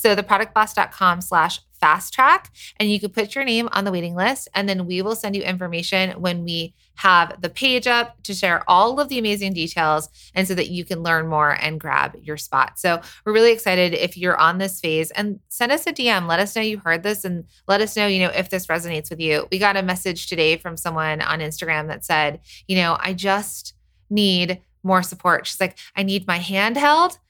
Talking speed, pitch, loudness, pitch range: 225 wpm, 185 Hz, -20 LUFS, 170-210 Hz